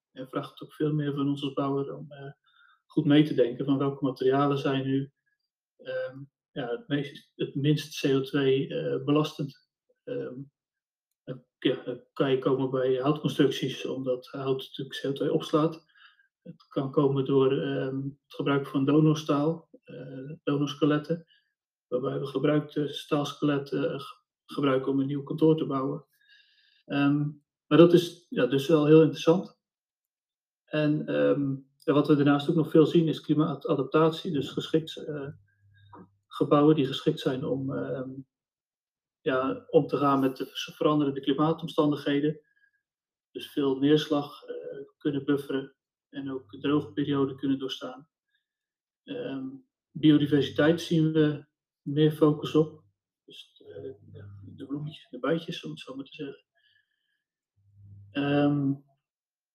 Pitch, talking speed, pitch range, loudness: 145 Hz, 135 wpm, 135-160 Hz, -27 LUFS